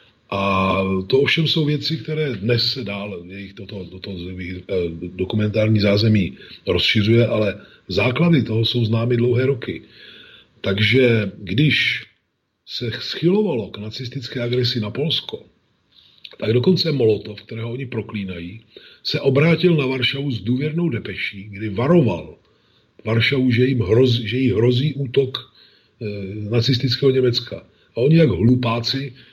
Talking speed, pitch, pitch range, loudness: 125 wpm, 120 Hz, 105-135 Hz, -19 LUFS